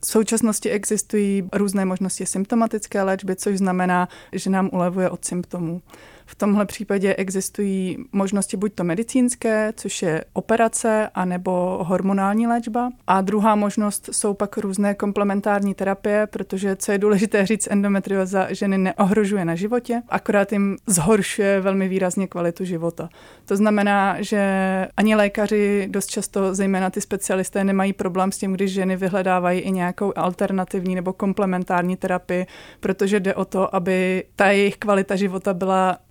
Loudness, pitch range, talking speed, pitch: -21 LUFS, 185-210 Hz, 145 wpm, 195 Hz